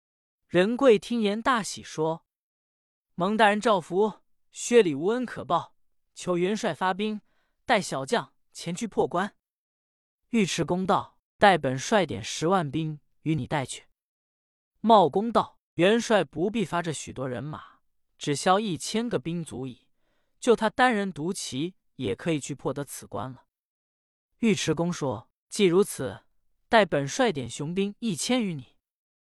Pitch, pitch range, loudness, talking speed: 180 Hz, 145-215 Hz, -26 LUFS, 200 characters per minute